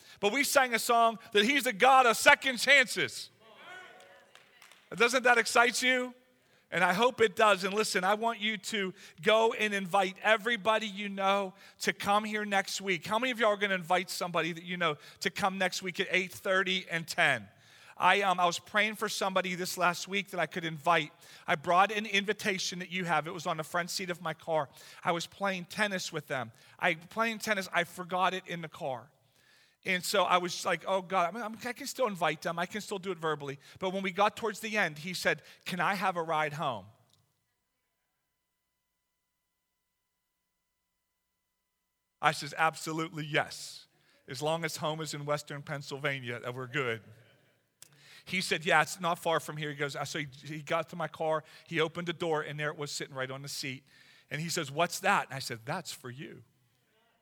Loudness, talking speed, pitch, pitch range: -30 LUFS, 200 wpm, 180 Hz, 155-205 Hz